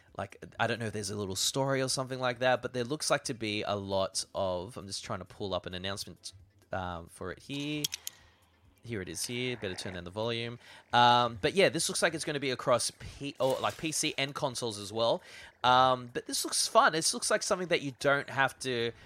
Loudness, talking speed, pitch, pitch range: -31 LUFS, 240 wpm, 120 Hz, 100-140 Hz